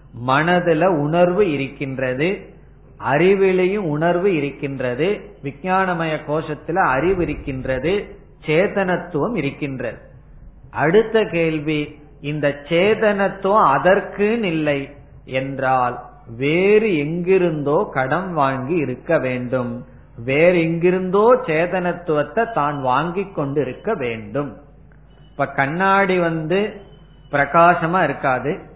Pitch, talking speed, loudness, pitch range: 155 Hz, 80 wpm, -19 LUFS, 140-185 Hz